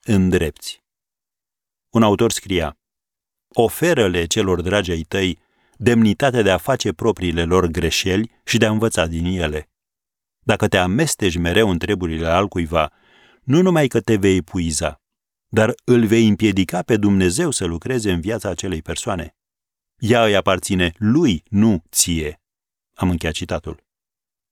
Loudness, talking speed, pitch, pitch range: -18 LUFS, 140 wpm, 95 Hz, 85-110 Hz